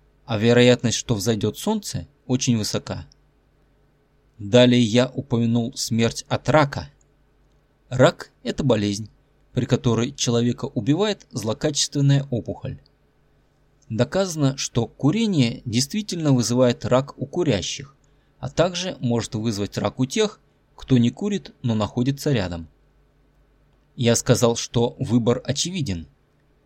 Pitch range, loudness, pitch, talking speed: 120-140 Hz, -22 LUFS, 130 Hz, 110 wpm